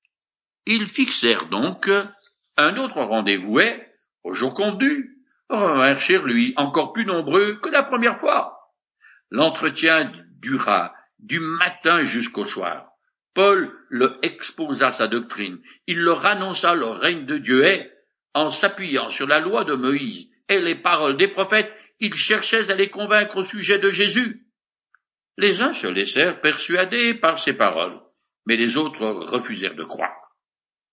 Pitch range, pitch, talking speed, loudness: 165-235 Hz, 200 Hz, 145 wpm, -20 LUFS